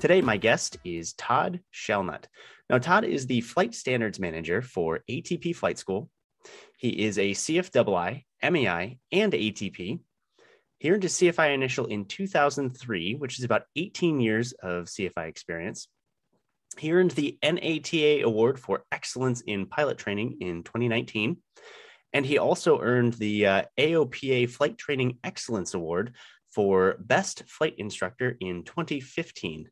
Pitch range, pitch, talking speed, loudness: 105-155 Hz, 125 Hz, 145 wpm, -27 LUFS